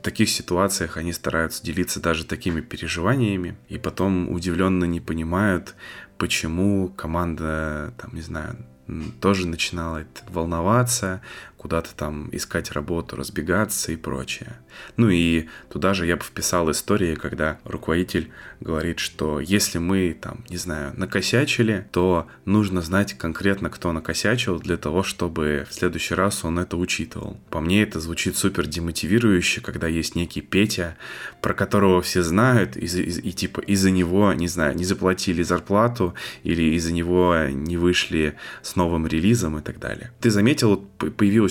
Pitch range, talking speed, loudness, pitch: 80-100 Hz, 145 wpm, -23 LUFS, 90 Hz